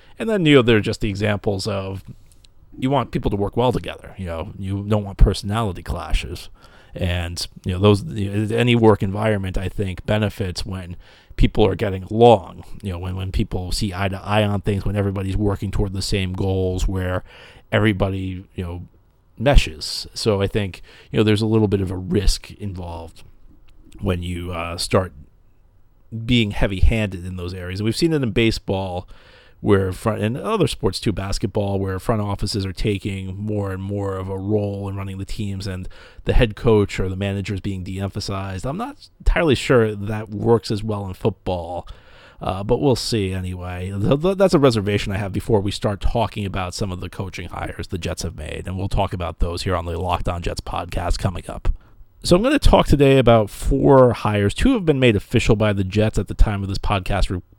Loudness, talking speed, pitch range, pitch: -21 LUFS, 205 wpm, 95-110 Hz, 100 Hz